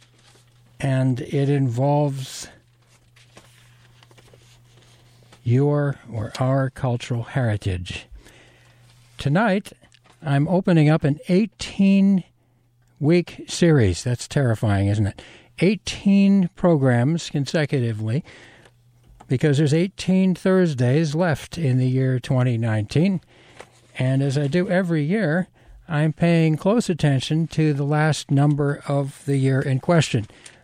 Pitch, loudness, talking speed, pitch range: 135 Hz, -21 LUFS, 100 wpm, 120-160 Hz